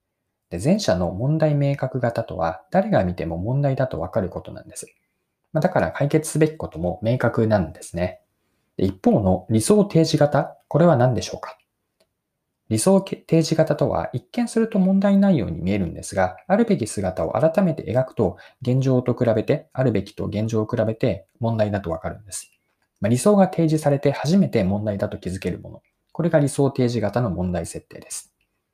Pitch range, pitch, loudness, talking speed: 95-150 Hz, 120 Hz, -21 LUFS, 350 characters per minute